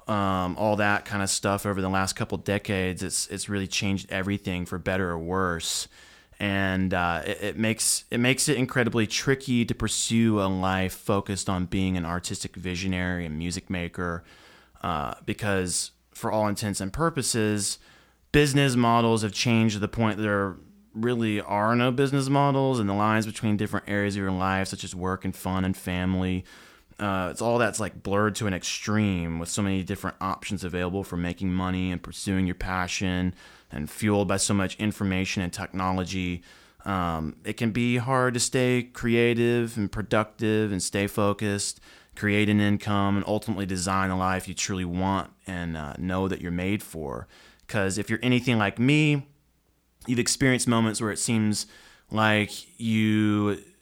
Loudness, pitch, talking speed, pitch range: -26 LUFS, 100 Hz, 170 wpm, 95-110 Hz